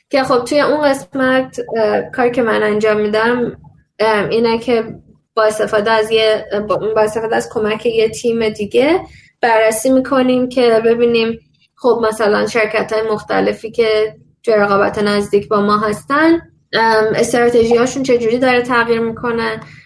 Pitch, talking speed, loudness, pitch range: 225 Hz, 135 wpm, -14 LUFS, 215-245 Hz